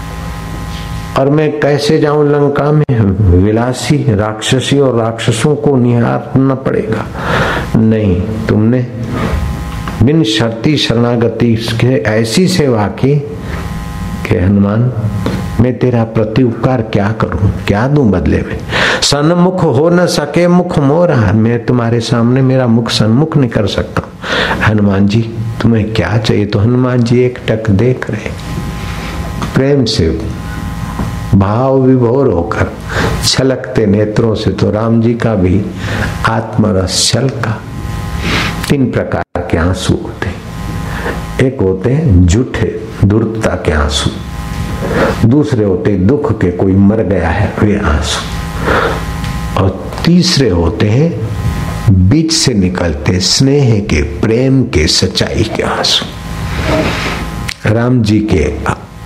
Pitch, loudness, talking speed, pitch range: 110 Hz, -12 LUFS, 110 wpm, 95-125 Hz